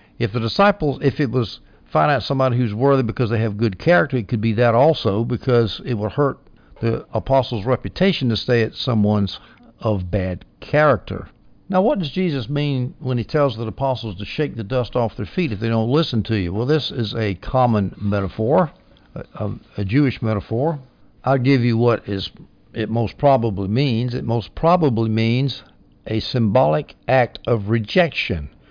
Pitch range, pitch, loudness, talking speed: 110-135 Hz, 120 Hz, -20 LUFS, 180 wpm